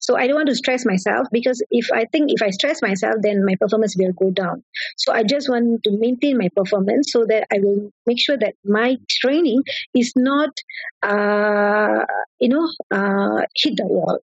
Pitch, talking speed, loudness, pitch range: 235 Hz, 200 wpm, -19 LUFS, 205-265 Hz